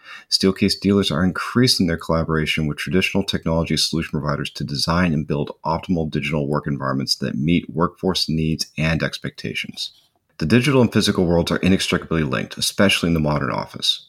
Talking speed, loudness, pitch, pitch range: 160 wpm, -20 LUFS, 80 Hz, 75-95 Hz